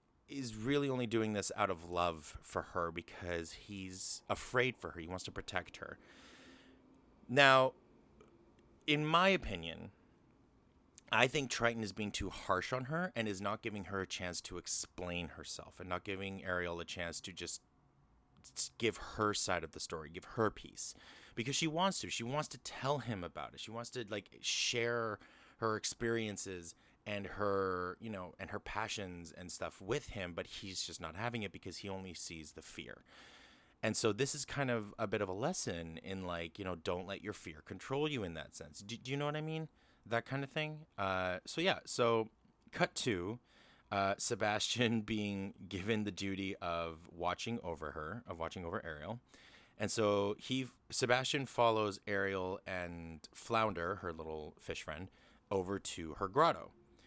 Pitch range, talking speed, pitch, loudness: 90-115 Hz, 180 wpm, 100 Hz, -38 LUFS